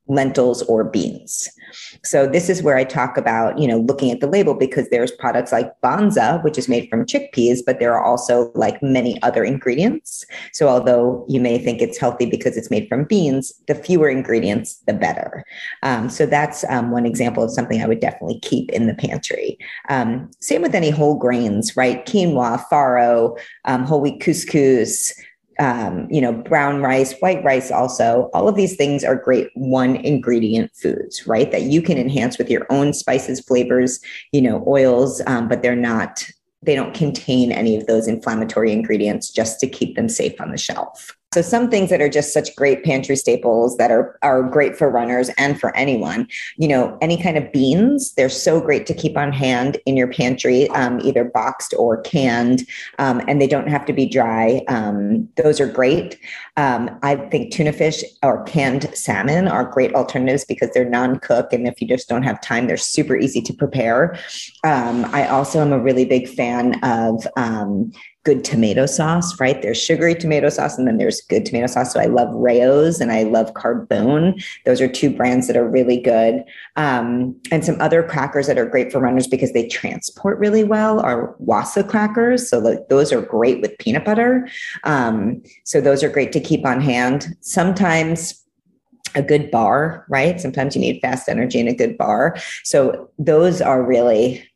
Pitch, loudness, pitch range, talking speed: 135 Hz, -18 LUFS, 125-160 Hz, 190 wpm